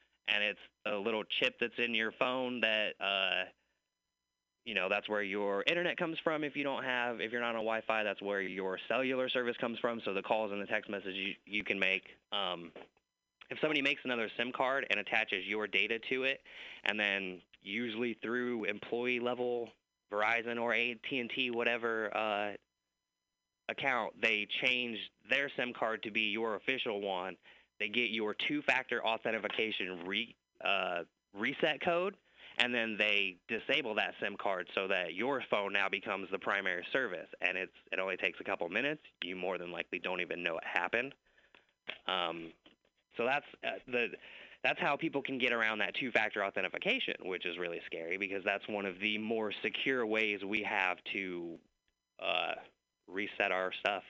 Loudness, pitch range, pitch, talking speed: -34 LUFS, 105-125 Hz, 110 Hz, 170 wpm